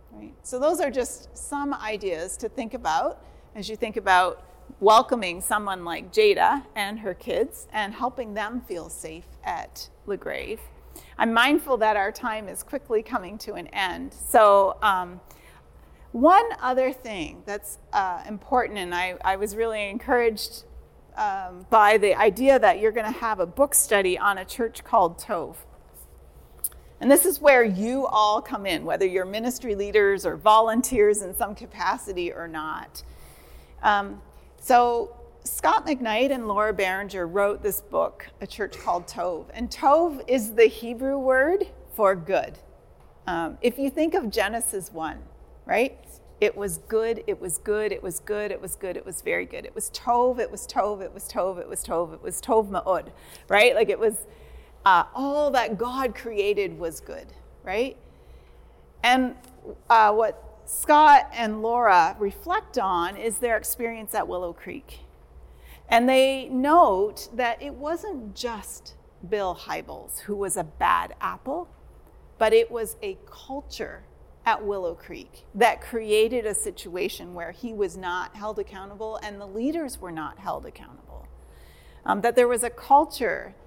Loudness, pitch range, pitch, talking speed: -24 LUFS, 185-260 Hz, 220 Hz, 160 wpm